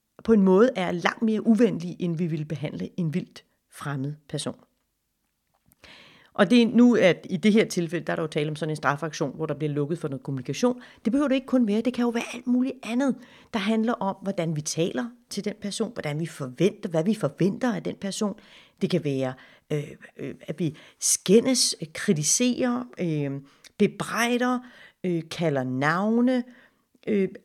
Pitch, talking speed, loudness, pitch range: 195 Hz, 175 wpm, -25 LUFS, 160-235 Hz